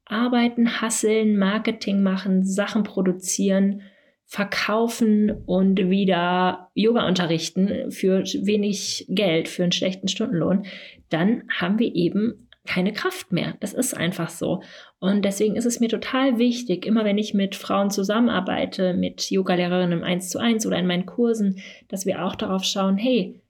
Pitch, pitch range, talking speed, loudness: 200 Hz, 185-225 Hz, 145 wpm, -22 LUFS